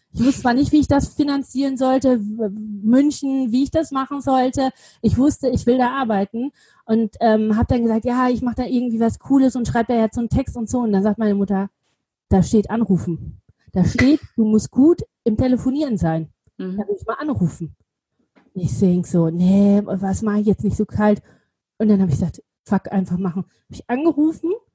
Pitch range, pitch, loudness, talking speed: 205-265 Hz, 230 Hz, -19 LUFS, 210 wpm